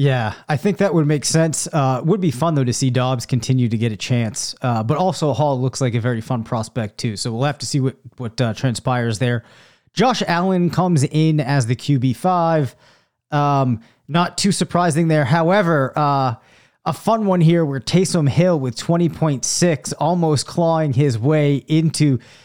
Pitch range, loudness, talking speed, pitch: 125-165 Hz, -18 LUFS, 190 wpm, 145 Hz